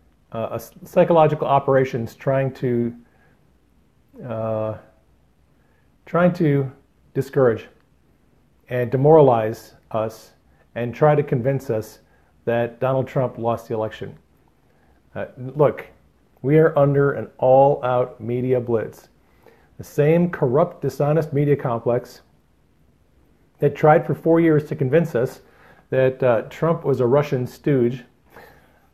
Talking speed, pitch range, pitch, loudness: 110 wpm, 115-145 Hz, 130 Hz, -20 LUFS